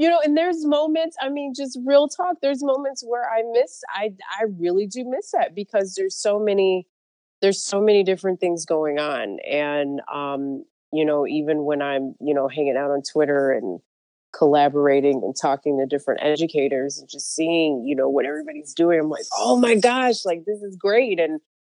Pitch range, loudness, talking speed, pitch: 145-230 Hz, -22 LUFS, 195 wpm, 170 Hz